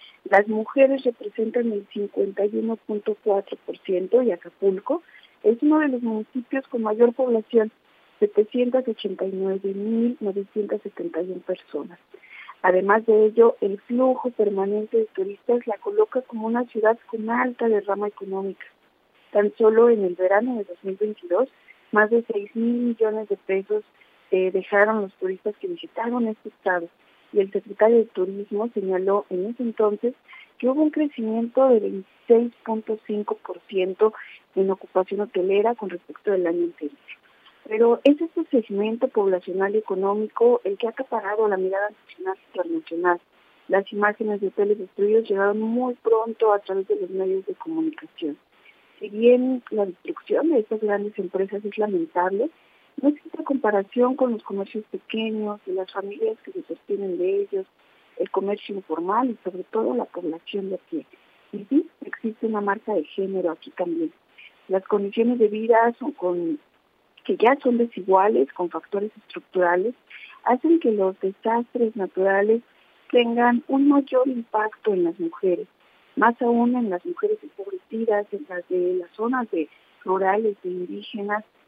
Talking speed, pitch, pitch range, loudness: 140 wpm, 215 Hz, 195-240 Hz, -23 LUFS